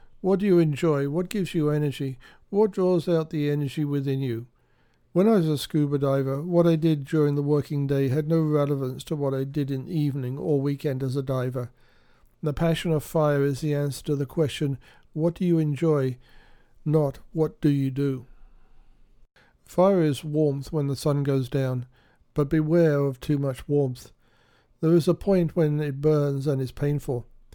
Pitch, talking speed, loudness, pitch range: 145 Hz, 185 wpm, -25 LUFS, 135-160 Hz